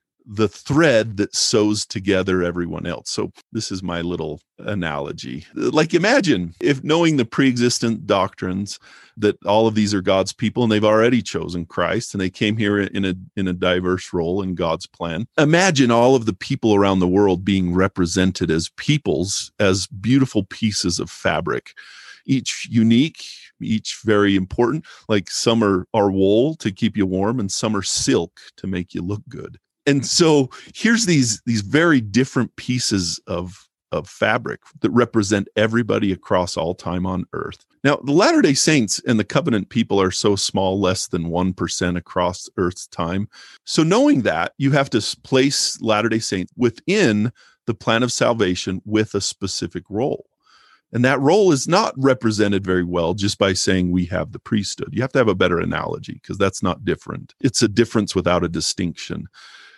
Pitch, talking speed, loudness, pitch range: 105 Hz, 175 wpm, -19 LUFS, 95-120 Hz